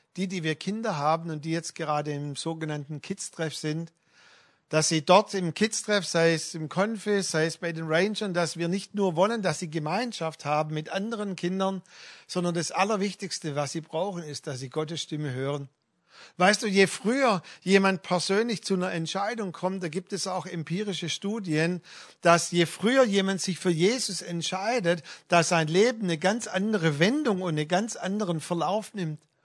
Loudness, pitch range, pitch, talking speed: -27 LUFS, 160-195 Hz, 175 Hz, 180 wpm